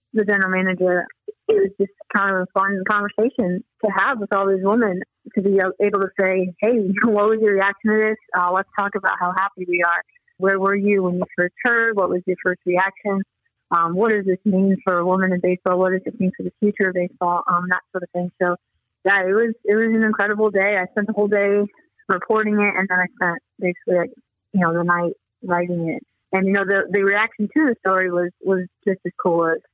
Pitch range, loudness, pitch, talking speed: 180-210 Hz, -20 LUFS, 195 Hz, 235 wpm